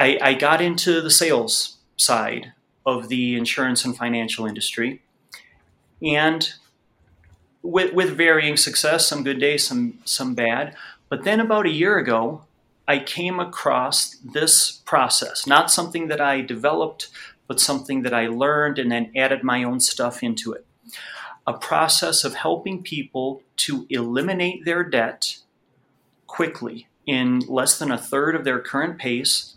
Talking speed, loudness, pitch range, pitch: 140 wpm, -20 LUFS, 125-160 Hz, 135 Hz